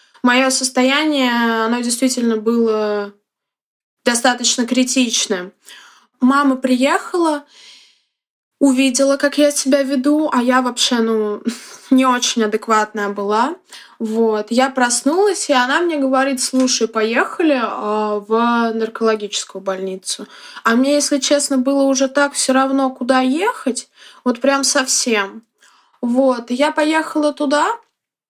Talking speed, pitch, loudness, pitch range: 110 wpm, 255 Hz, -16 LUFS, 225-280 Hz